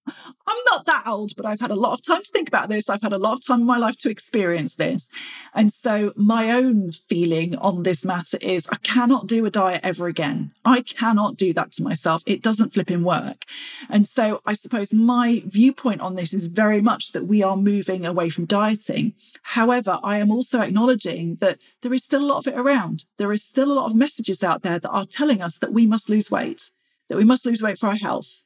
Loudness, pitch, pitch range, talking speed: -21 LUFS, 215 Hz, 195-245 Hz, 235 wpm